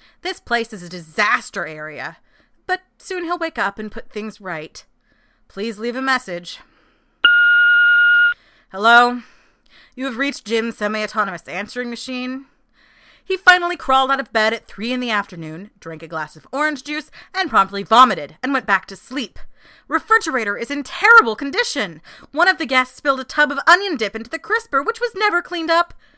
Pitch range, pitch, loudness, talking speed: 210-345 Hz, 260 Hz, -17 LUFS, 175 wpm